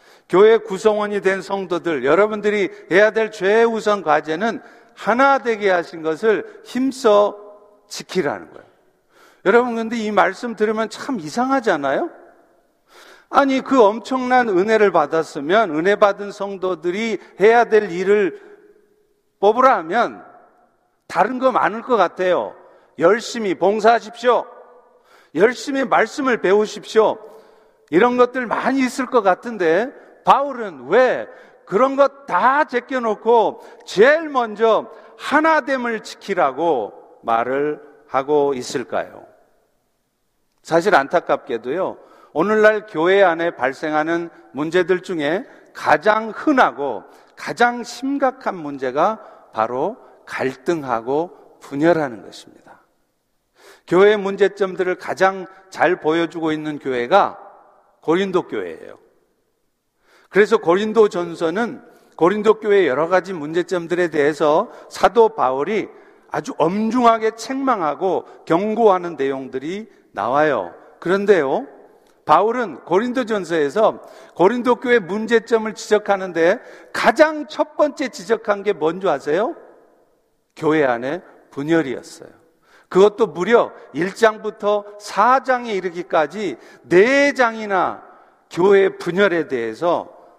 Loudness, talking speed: -18 LUFS, 250 characters per minute